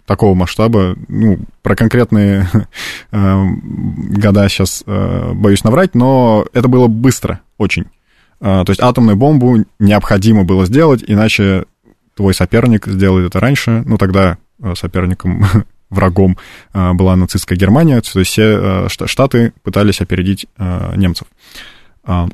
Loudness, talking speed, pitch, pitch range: -12 LUFS, 130 wpm, 100 Hz, 95-115 Hz